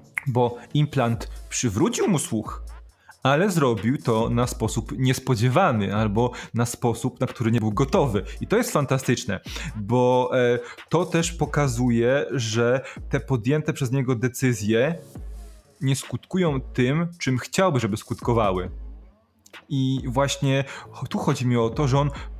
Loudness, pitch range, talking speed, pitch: -23 LUFS, 115-140 Hz, 130 wpm, 125 Hz